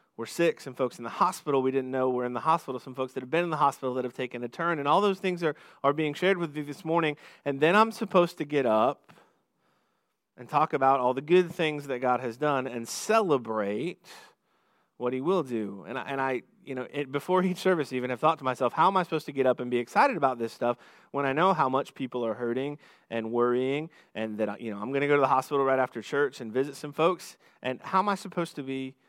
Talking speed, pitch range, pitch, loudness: 260 wpm, 125-160 Hz, 135 Hz, -28 LUFS